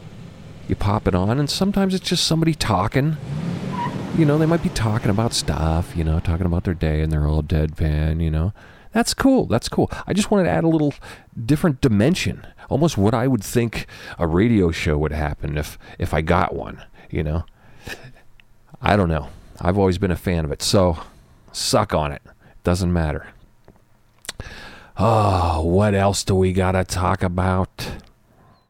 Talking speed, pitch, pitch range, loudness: 180 wpm, 100 Hz, 85-130 Hz, -20 LUFS